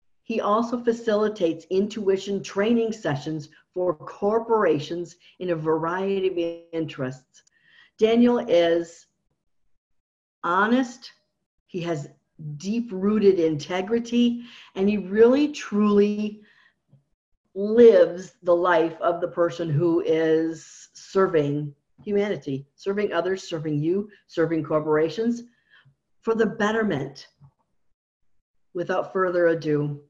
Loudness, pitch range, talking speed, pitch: -23 LUFS, 160-210 Hz, 95 wpm, 180 Hz